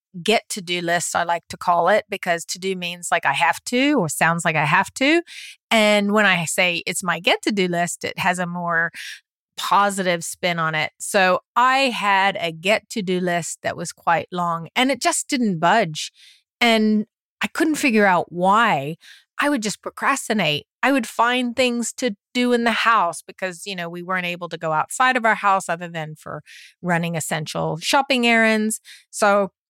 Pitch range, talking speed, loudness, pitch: 170-230 Hz, 195 wpm, -20 LUFS, 190 Hz